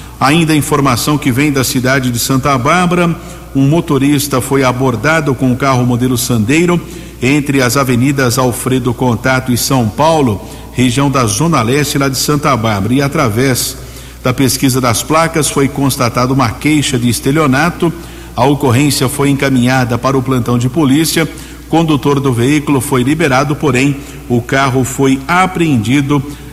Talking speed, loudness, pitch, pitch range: 150 wpm, -12 LUFS, 135 Hz, 130-150 Hz